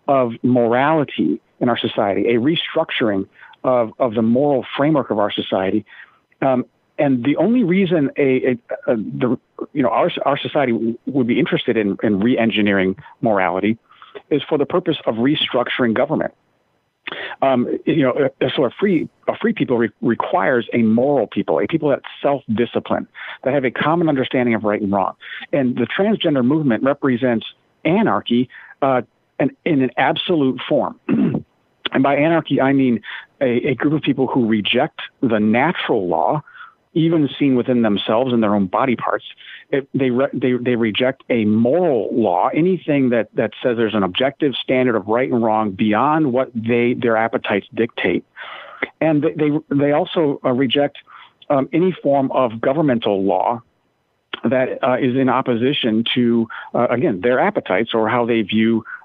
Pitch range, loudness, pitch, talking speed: 115-140 Hz, -18 LUFS, 125 Hz, 165 wpm